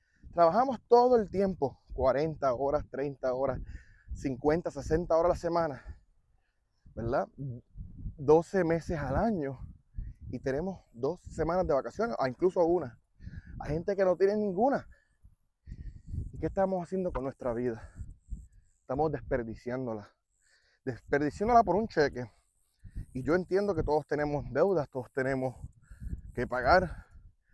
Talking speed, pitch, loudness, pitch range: 125 wpm, 135 Hz, -30 LUFS, 100-165 Hz